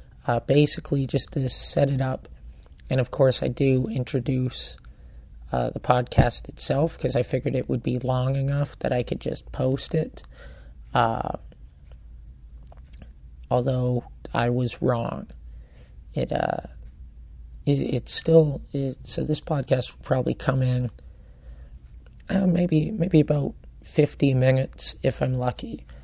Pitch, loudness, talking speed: 125 Hz, -25 LUFS, 130 wpm